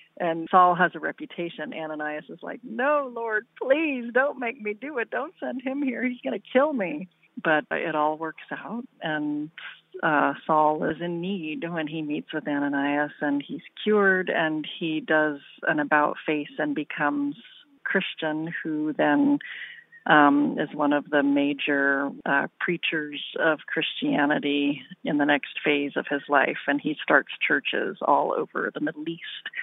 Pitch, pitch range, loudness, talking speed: 160 Hz, 150-240 Hz, -25 LUFS, 165 wpm